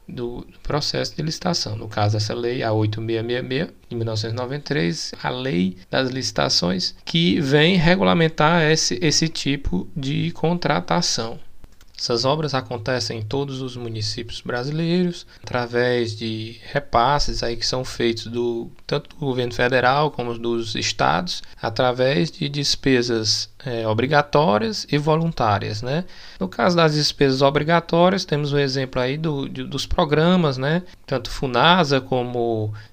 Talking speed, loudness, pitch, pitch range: 130 wpm, -21 LUFS, 130 Hz, 115-150 Hz